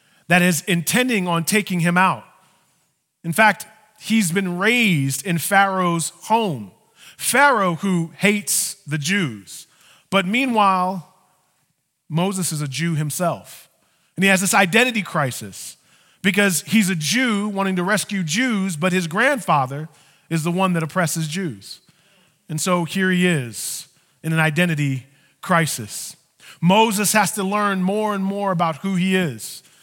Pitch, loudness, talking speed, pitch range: 185 Hz, -19 LUFS, 140 wpm, 165-200 Hz